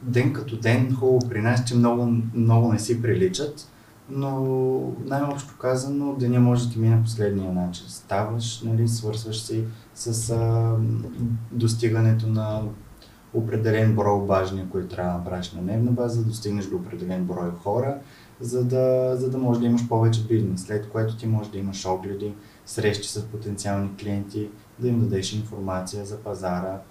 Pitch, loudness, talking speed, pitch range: 115 Hz, -24 LUFS, 165 wpm, 100-120 Hz